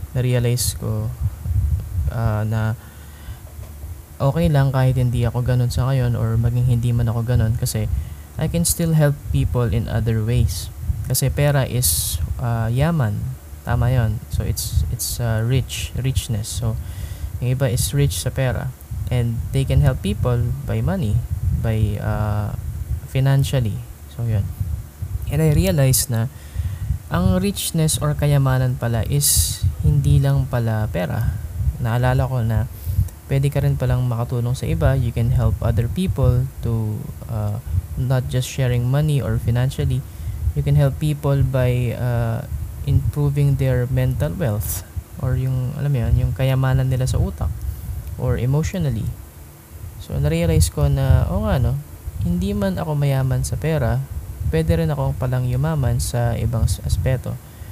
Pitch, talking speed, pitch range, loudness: 115 Hz, 145 wpm, 95-130 Hz, -20 LUFS